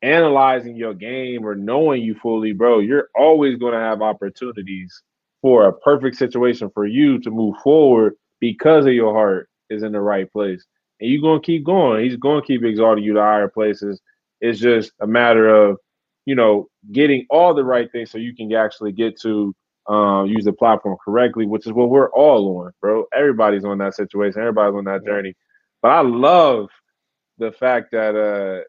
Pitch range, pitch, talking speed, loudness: 105-125 Hz, 110 Hz, 190 wpm, -16 LUFS